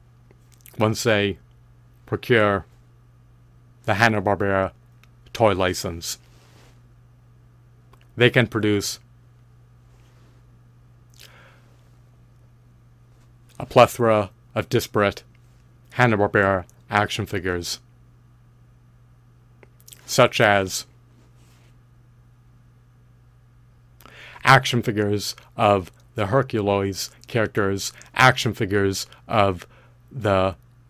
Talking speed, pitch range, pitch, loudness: 55 wpm, 110-120 Hz, 120 Hz, -21 LUFS